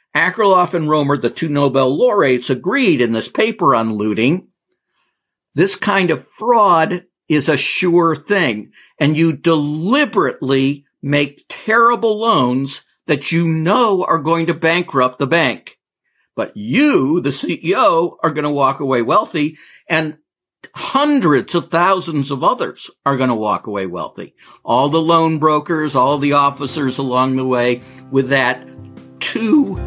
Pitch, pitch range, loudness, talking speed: 150 Hz, 135-170 Hz, -15 LUFS, 145 wpm